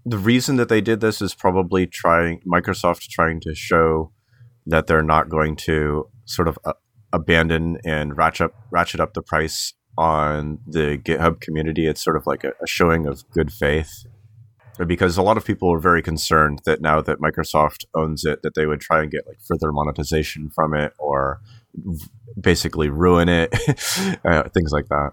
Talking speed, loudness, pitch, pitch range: 185 wpm, -20 LUFS, 80 Hz, 75-95 Hz